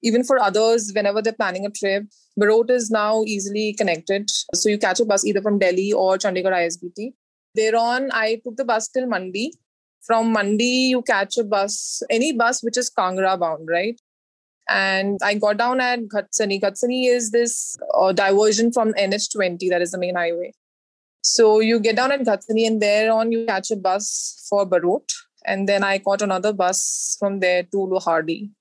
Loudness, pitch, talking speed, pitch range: -20 LUFS, 210 Hz, 180 wpm, 195-230 Hz